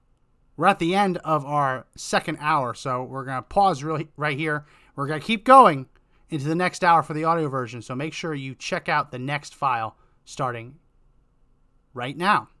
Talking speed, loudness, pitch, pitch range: 195 wpm, -23 LUFS, 150 Hz, 130-165 Hz